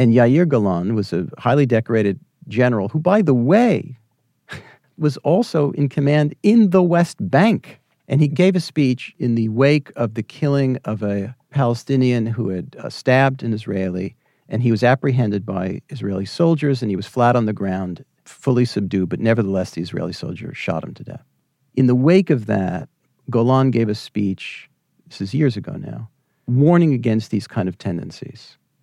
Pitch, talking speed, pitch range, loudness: 125 Hz, 175 wpm, 105-145 Hz, -19 LUFS